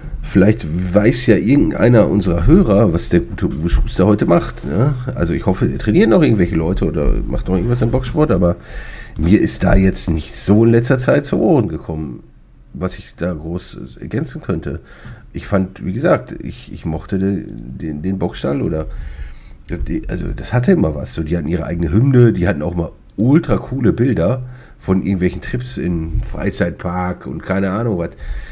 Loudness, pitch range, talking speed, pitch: -16 LUFS, 85-110 Hz, 180 wpm, 95 Hz